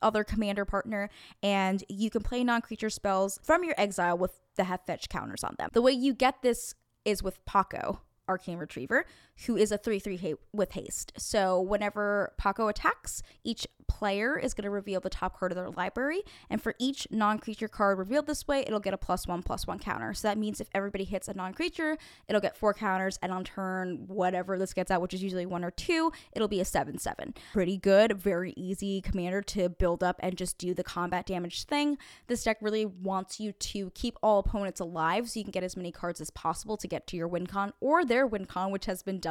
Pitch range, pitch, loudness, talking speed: 185-220 Hz, 200 Hz, -31 LUFS, 230 wpm